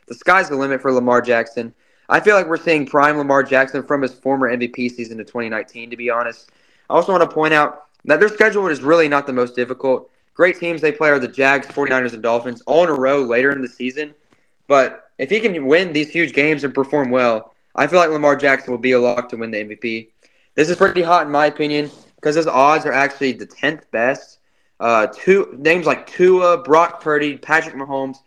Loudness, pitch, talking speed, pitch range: -16 LUFS, 140 Hz, 225 wpm, 125-155 Hz